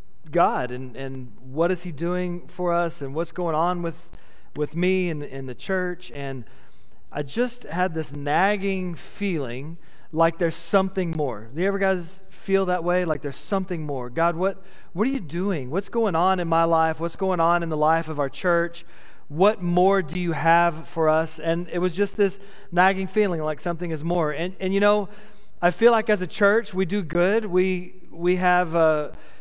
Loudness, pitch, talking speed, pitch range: -24 LUFS, 175 Hz, 200 wpm, 160-190 Hz